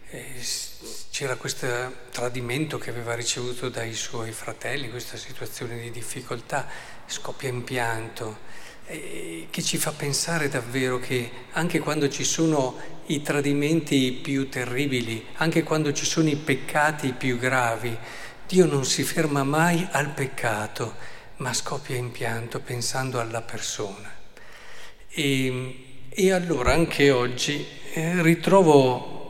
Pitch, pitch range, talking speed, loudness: 130 Hz, 125-150 Hz, 120 wpm, -25 LUFS